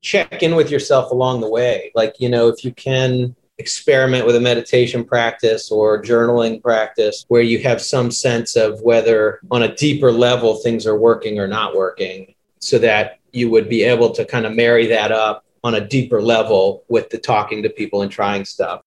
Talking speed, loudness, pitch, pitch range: 195 wpm, -16 LUFS, 120 Hz, 110-125 Hz